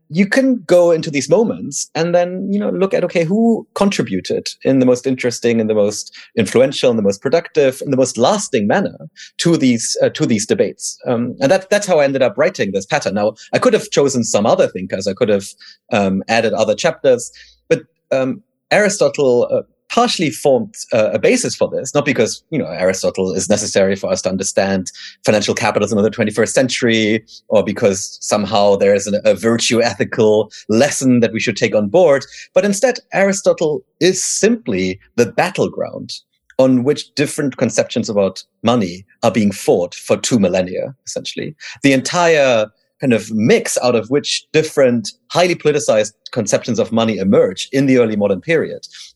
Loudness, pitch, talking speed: -16 LUFS, 145 Hz, 180 wpm